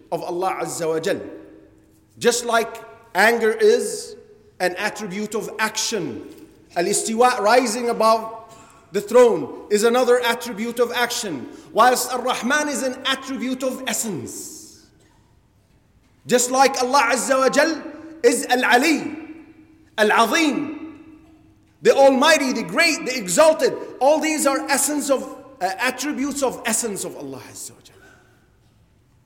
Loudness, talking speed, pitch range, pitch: -19 LUFS, 130 wpm, 205-280 Hz, 245 Hz